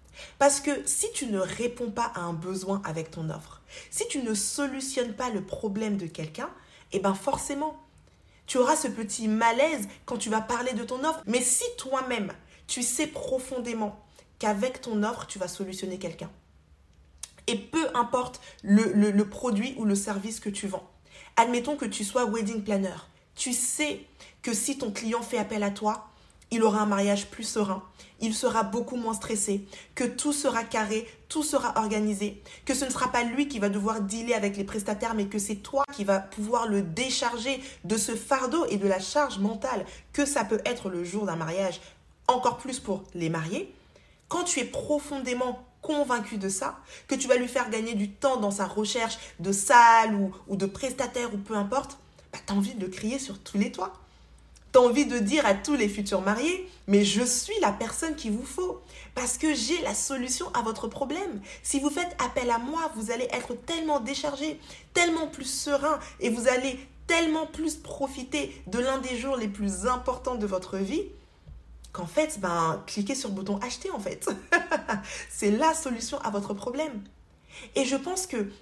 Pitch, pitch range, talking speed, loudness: 235 Hz, 205-270 Hz, 190 wpm, -28 LUFS